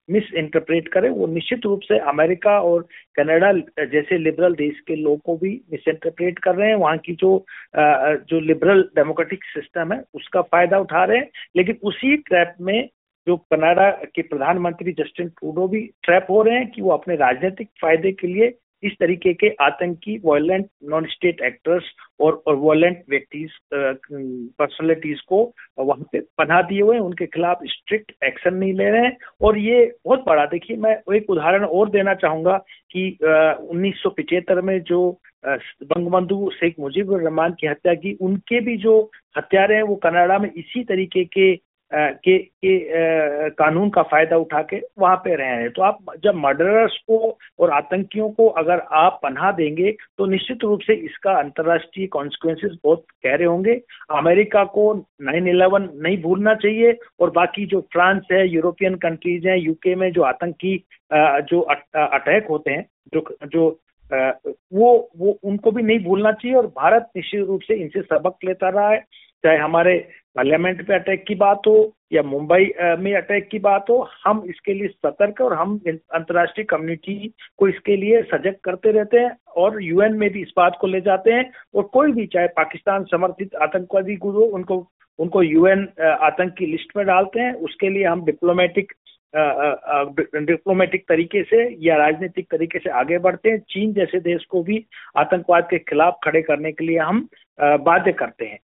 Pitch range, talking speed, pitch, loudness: 165-205 Hz, 165 wpm, 185 Hz, -19 LUFS